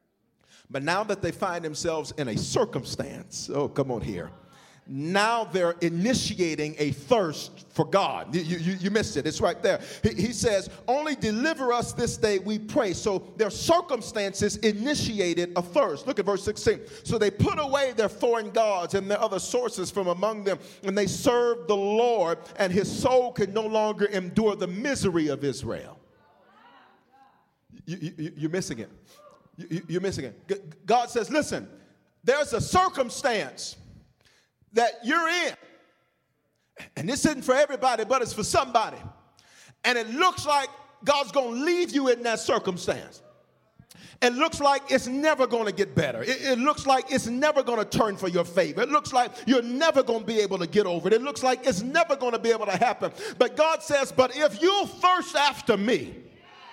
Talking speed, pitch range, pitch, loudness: 180 wpm, 190-265 Hz, 225 Hz, -26 LUFS